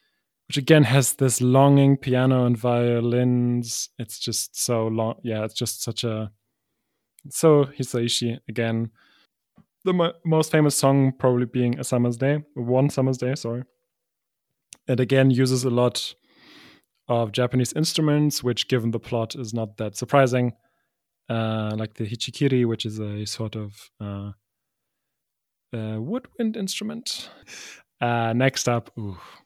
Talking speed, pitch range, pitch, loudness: 135 wpm, 115-135 Hz, 125 Hz, -23 LUFS